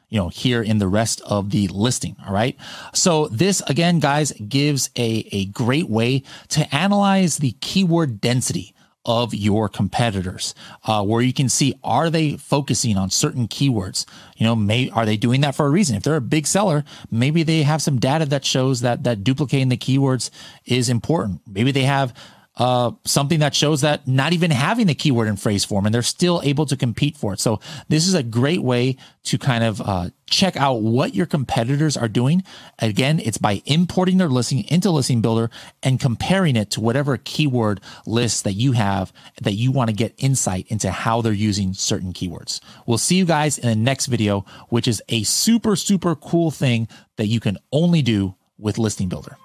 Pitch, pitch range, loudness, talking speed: 130 Hz, 110-150 Hz, -20 LUFS, 200 wpm